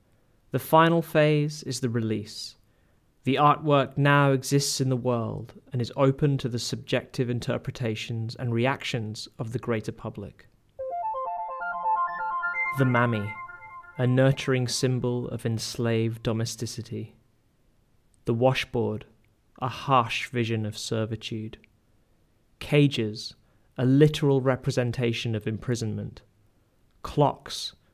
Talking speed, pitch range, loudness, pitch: 105 wpm, 115-135 Hz, -26 LUFS, 120 Hz